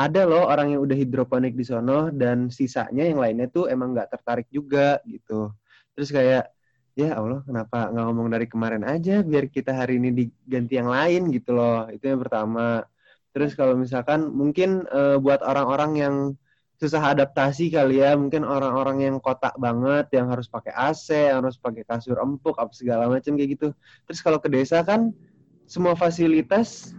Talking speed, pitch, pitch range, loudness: 175 wpm, 135 Hz, 125-150 Hz, -23 LUFS